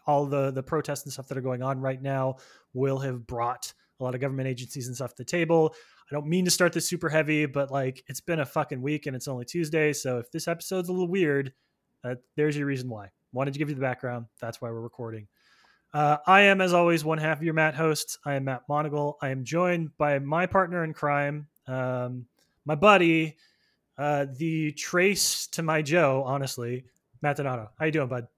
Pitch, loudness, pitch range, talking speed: 145 Hz, -27 LUFS, 130-160 Hz, 225 wpm